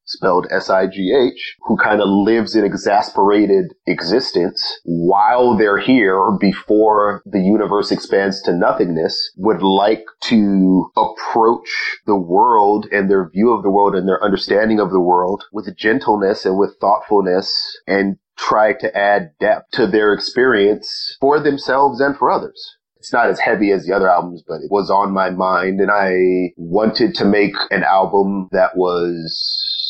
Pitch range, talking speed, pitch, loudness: 95-110 Hz, 155 wpm, 100 Hz, -15 LUFS